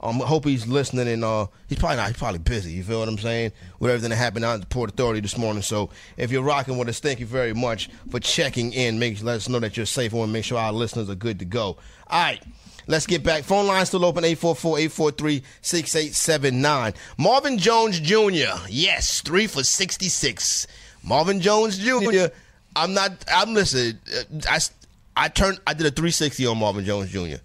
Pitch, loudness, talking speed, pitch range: 130 Hz, -22 LUFS, 210 wpm, 115-165 Hz